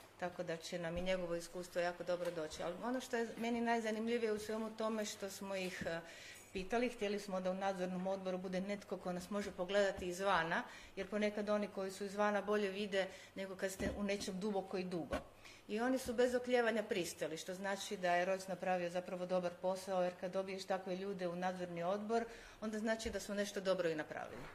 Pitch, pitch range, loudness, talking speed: 195 Hz, 180-210 Hz, -40 LUFS, 205 wpm